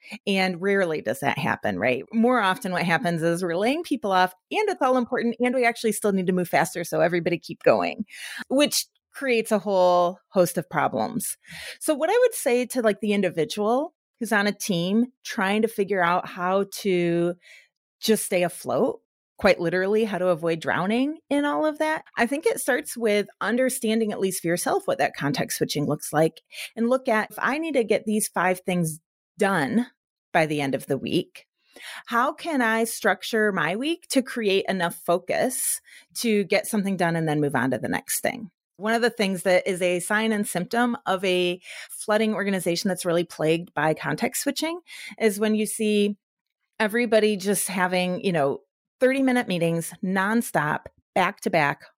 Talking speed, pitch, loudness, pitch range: 185 wpm, 205 Hz, -24 LUFS, 180-235 Hz